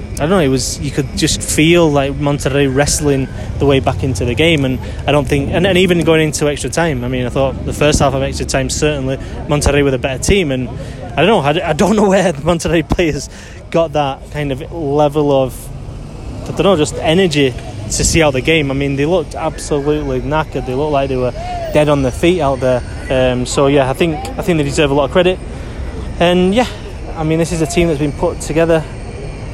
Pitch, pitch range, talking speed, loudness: 145 Hz, 130-160 Hz, 235 wpm, -14 LUFS